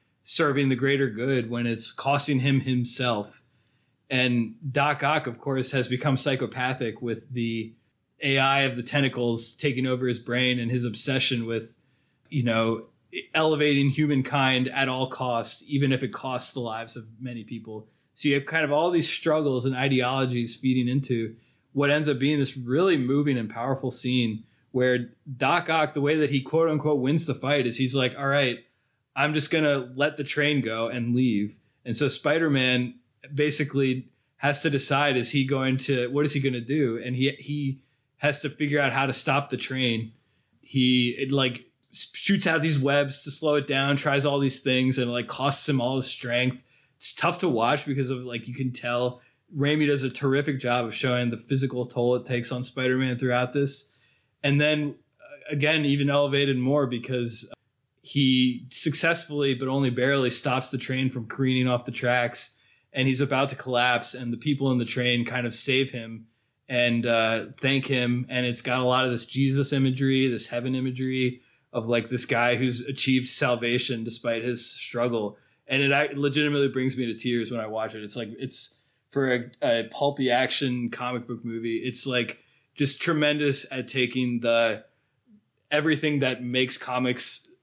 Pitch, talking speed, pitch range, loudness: 130 Hz, 185 wpm, 120-140 Hz, -24 LUFS